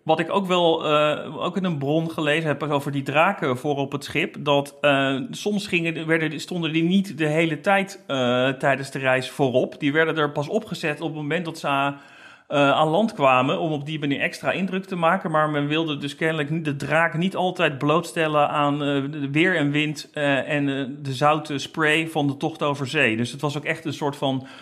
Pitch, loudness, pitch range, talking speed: 150 Hz, -22 LUFS, 140-165 Hz, 220 wpm